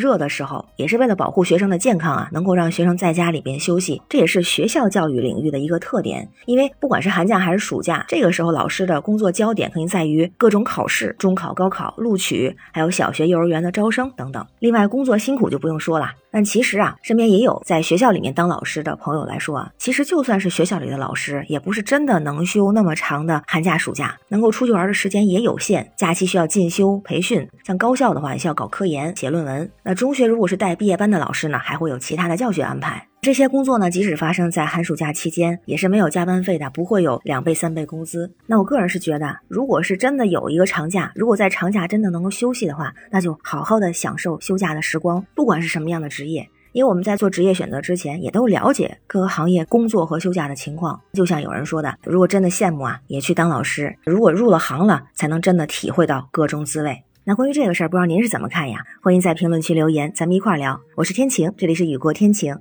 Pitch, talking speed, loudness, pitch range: 180 Hz, 375 characters per minute, -19 LUFS, 160-205 Hz